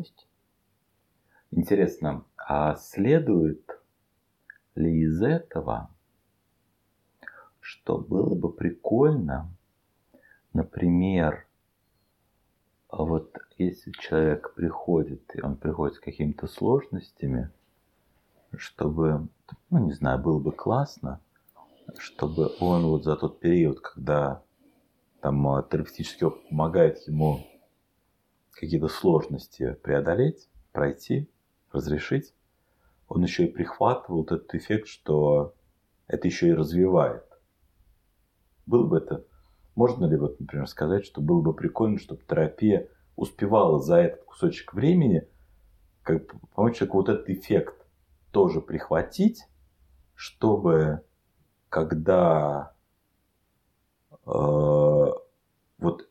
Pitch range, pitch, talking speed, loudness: 75-95 Hz, 80 Hz, 90 wpm, -26 LUFS